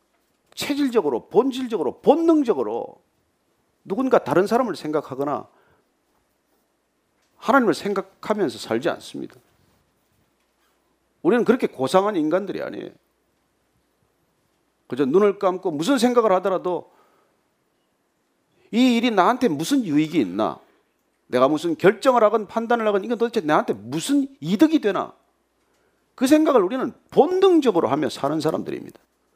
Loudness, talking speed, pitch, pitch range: -21 LUFS, 285 characters per minute, 235 Hz, 190-280 Hz